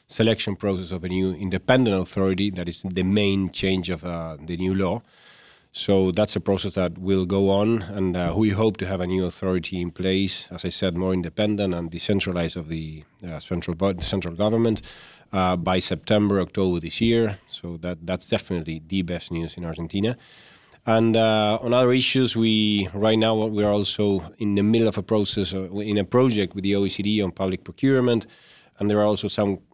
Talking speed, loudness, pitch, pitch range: 190 wpm, -23 LUFS, 95 Hz, 90-105 Hz